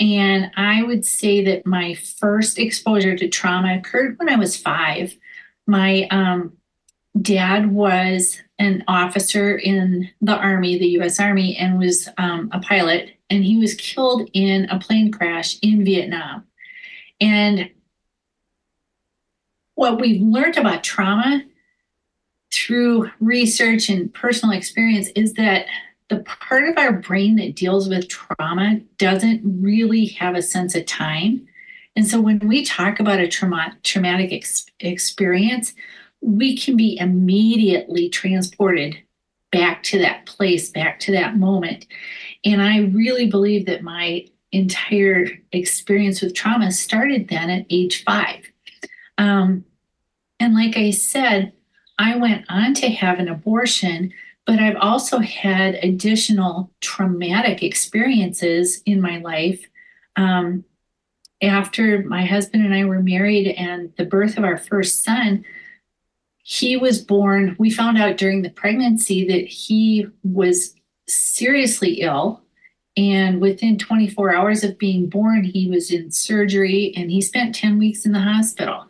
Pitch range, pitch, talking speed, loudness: 185-220 Hz, 200 Hz, 135 wpm, -18 LUFS